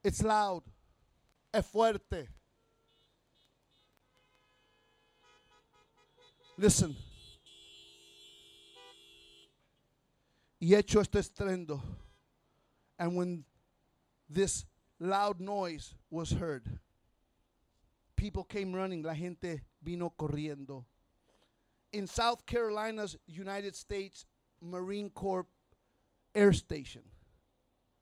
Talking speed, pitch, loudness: 60 wpm, 145 Hz, -34 LUFS